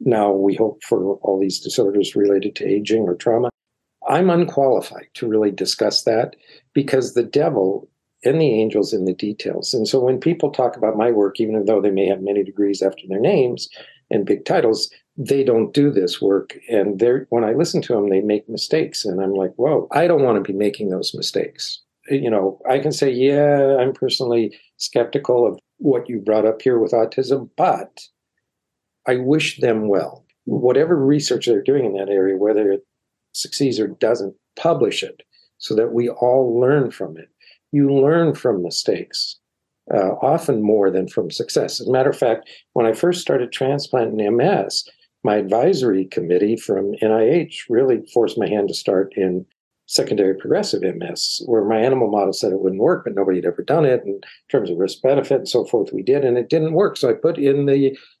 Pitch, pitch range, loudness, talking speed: 120 Hz, 100-140 Hz, -19 LUFS, 195 wpm